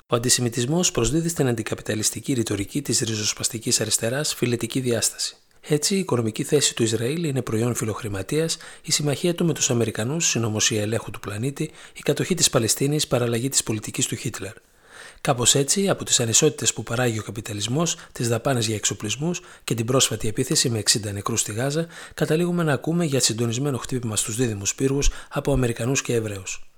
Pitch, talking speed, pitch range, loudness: 125 Hz, 165 wpm, 115-150 Hz, -23 LUFS